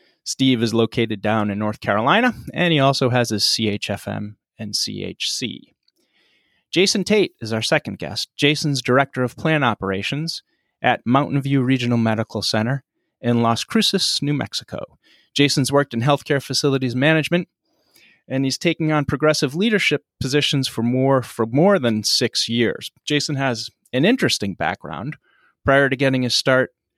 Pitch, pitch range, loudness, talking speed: 135 Hz, 115-145 Hz, -19 LUFS, 150 wpm